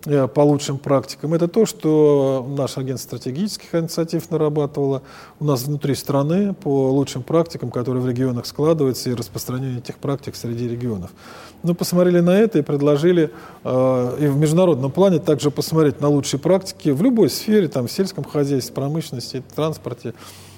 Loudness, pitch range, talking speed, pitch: -20 LUFS, 130-160 Hz, 155 wpm, 145 Hz